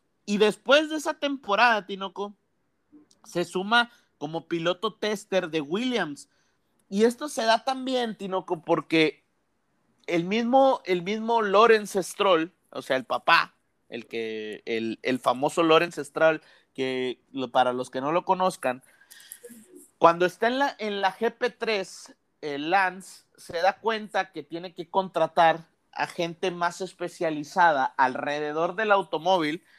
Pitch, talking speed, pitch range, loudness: 185 Hz, 135 wpm, 160-225 Hz, -25 LUFS